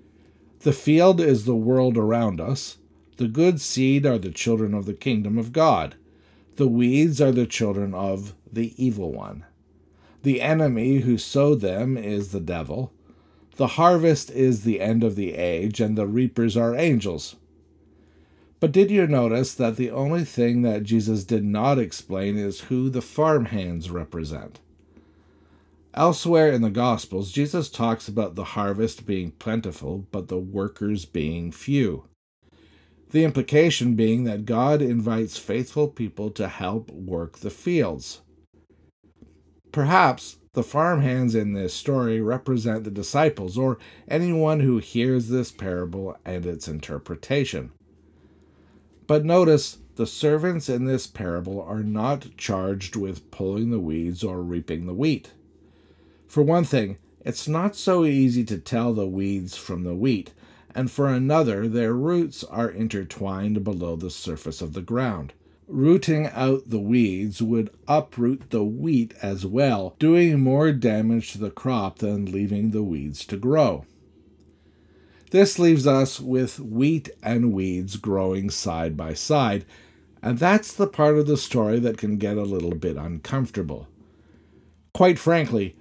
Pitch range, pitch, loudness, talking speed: 90-130 Hz, 110 Hz, -23 LUFS, 145 wpm